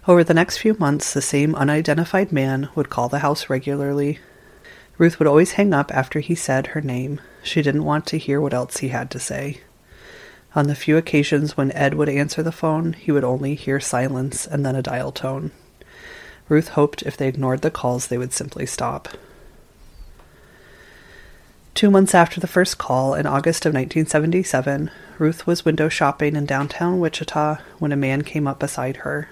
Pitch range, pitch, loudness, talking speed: 135-160 Hz, 145 Hz, -20 LUFS, 185 wpm